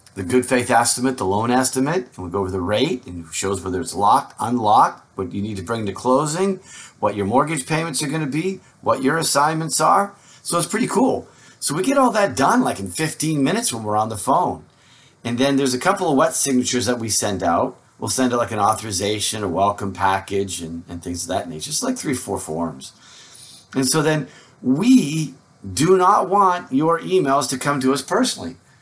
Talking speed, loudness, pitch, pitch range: 215 wpm, -19 LUFS, 130 Hz, 105-155 Hz